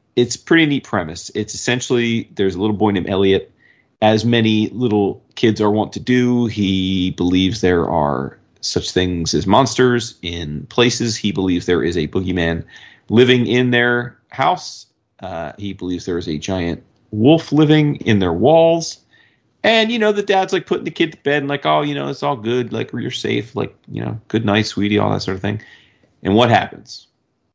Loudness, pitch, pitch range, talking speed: -17 LUFS, 110 Hz, 95-125 Hz, 190 wpm